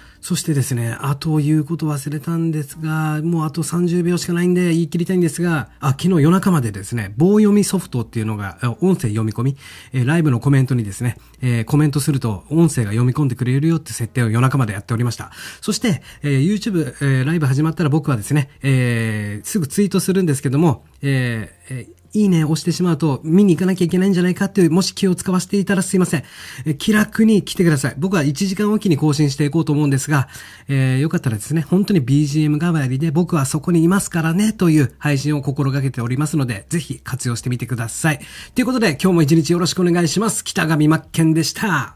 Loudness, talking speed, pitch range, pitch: -18 LUFS, 480 characters per minute, 130-175 Hz, 155 Hz